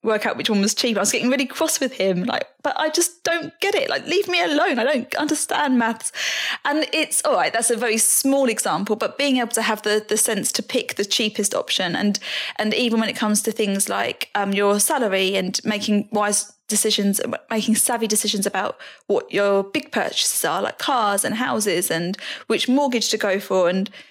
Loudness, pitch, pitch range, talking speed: -20 LUFS, 225 Hz, 205-275 Hz, 215 wpm